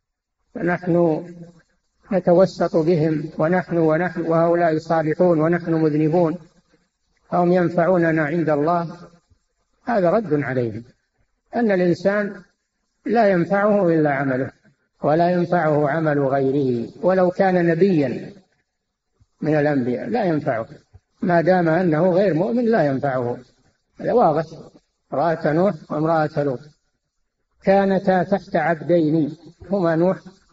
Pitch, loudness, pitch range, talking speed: 170 Hz, -19 LUFS, 155-180 Hz, 100 wpm